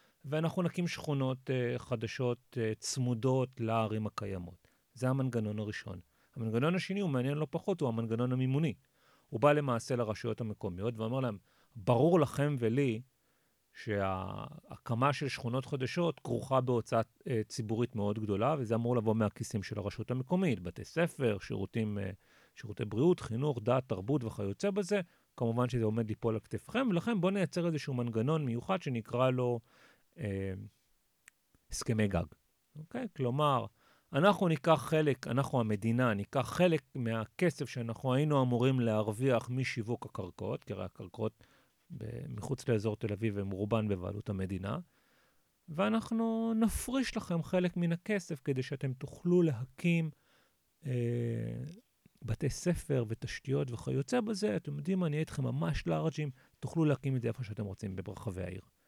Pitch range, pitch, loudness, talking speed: 110-150 Hz, 125 Hz, -34 LUFS, 140 wpm